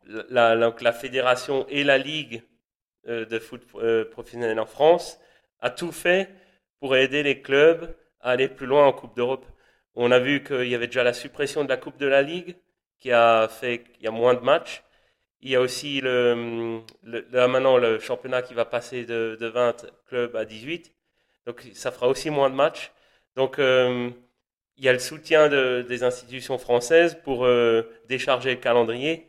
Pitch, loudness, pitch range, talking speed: 125 Hz, -23 LUFS, 120-140 Hz, 190 wpm